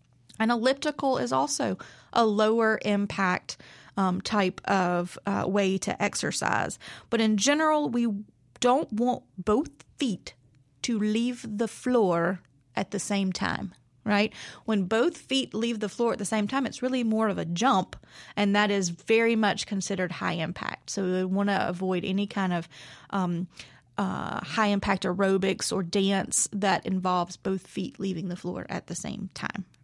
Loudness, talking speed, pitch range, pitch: -27 LUFS, 165 wpm, 185-225 Hz, 200 Hz